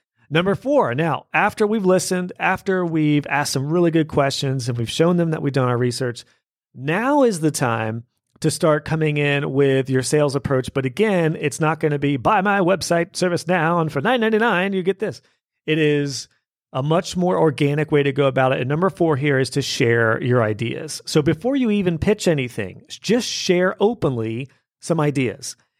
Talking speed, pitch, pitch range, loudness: 195 wpm, 155 Hz, 135-180 Hz, -20 LUFS